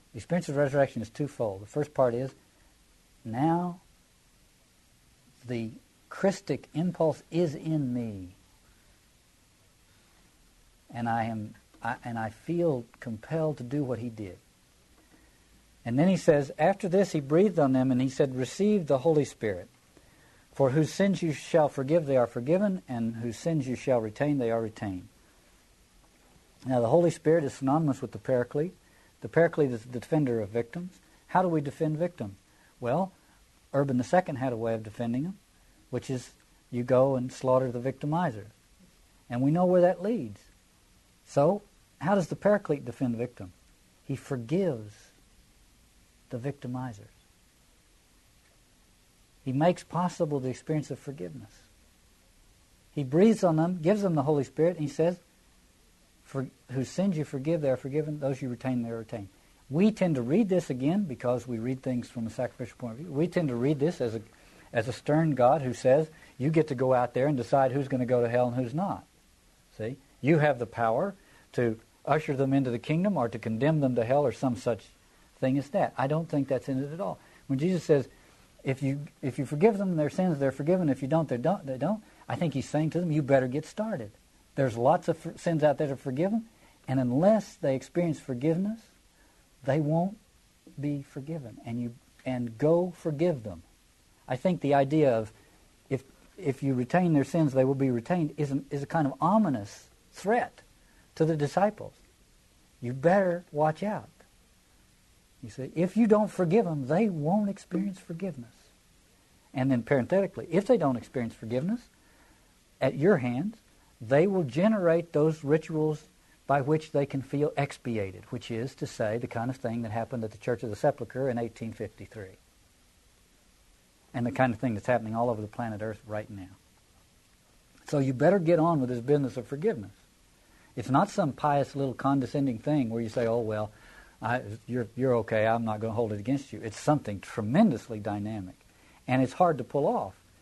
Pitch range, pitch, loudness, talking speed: 115-160 Hz, 135 Hz, -29 LUFS, 180 wpm